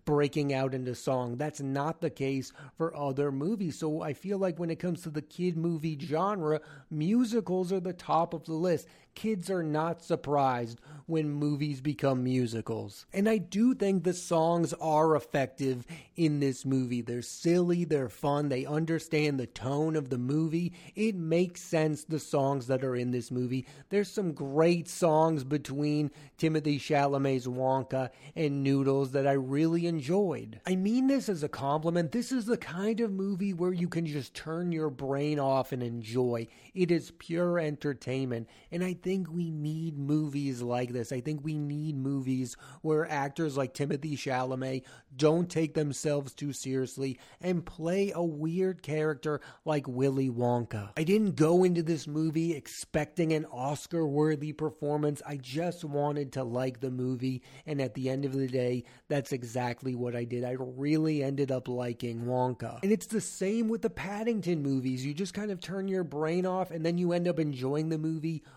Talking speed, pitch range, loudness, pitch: 180 wpm, 135-170 Hz, -31 LUFS, 150 Hz